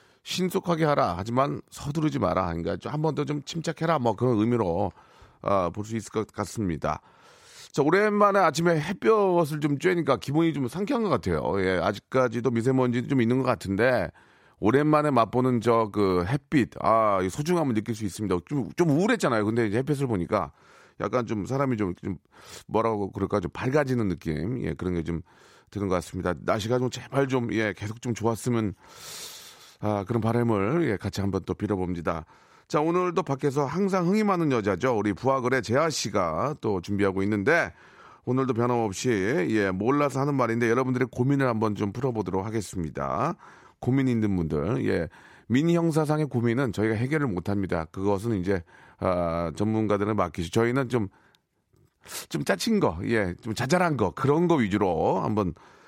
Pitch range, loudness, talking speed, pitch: 100-140 Hz, -26 LUFS, 350 characters per minute, 115 Hz